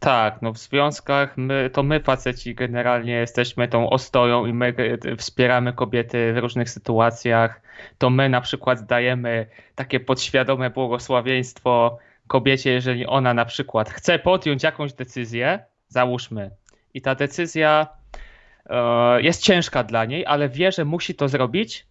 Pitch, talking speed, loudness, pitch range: 125 Hz, 140 wpm, -21 LUFS, 120-140 Hz